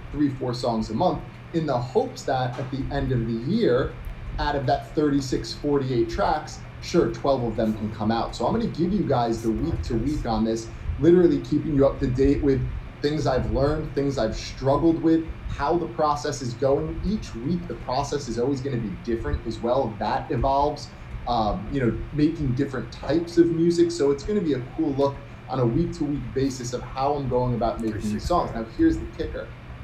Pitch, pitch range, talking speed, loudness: 135 Hz, 115-150 Hz, 210 wpm, -25 LUFS